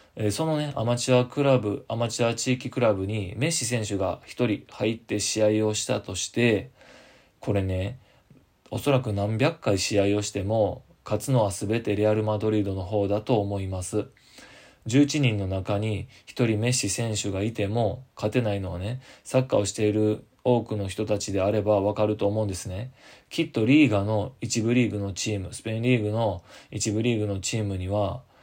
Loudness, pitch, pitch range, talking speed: -26 LUFS, 110 Hz, 100-120 Hz, 345 characters per minute